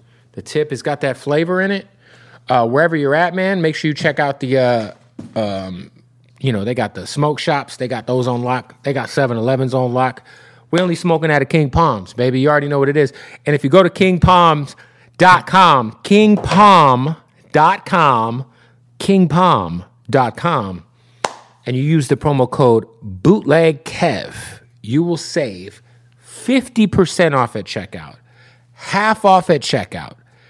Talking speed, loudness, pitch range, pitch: 155 wpm, -15 LUFS, 120-165 Hz, 135 Hz